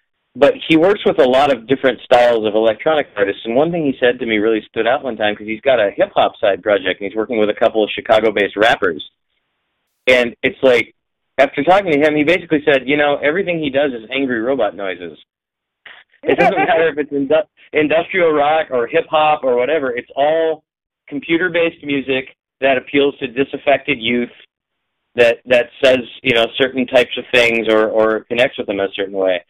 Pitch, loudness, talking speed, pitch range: 130 Hz, -15 LUFS, 205 wpm, 115-150 Hz